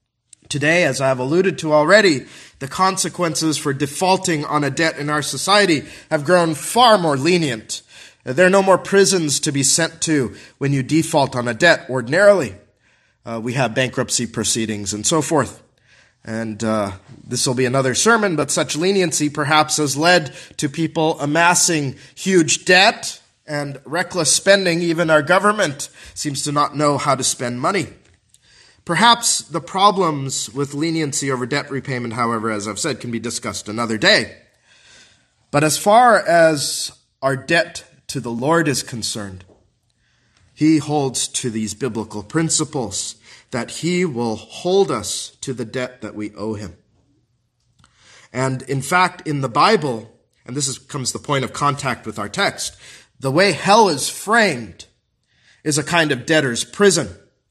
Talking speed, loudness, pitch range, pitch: 160 wpm, -17 LUFS, 120-165 Hz, 145 Hz